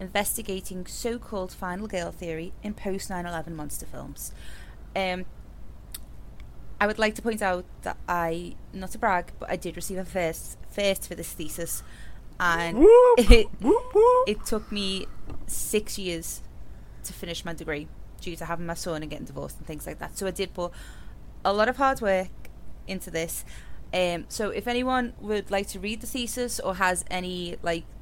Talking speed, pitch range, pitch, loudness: 170 wpm, 170-215 Hz, 190 Hz, -26 LUFS